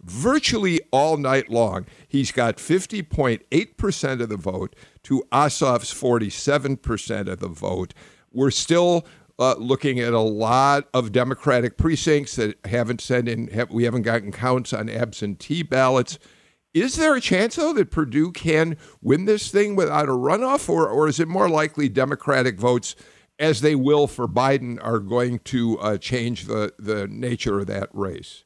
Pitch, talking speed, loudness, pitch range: 130 Hz, 160 wpm, -22 LUFS, 115-155 Hz